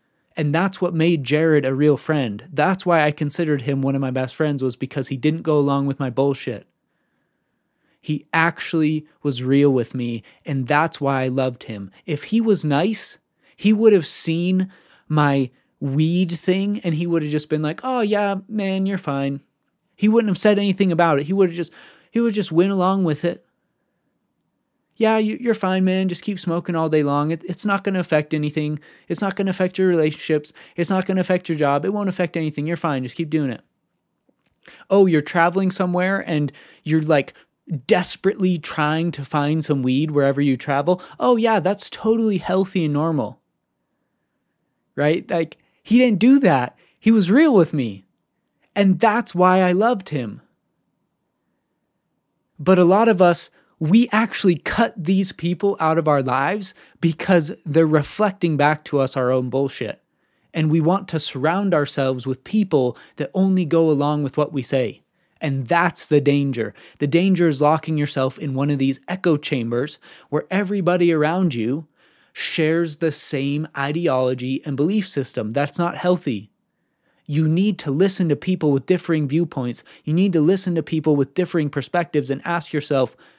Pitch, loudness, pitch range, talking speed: 160 Hz, -20 LUFS, 145-185 Hz, 180 wpm